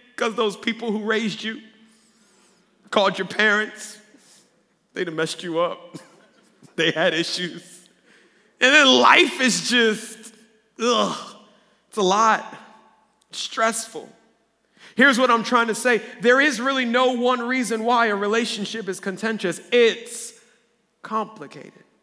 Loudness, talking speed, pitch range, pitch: -20 LUFS, 130 wpm, 205-235 Hz, 220 Hz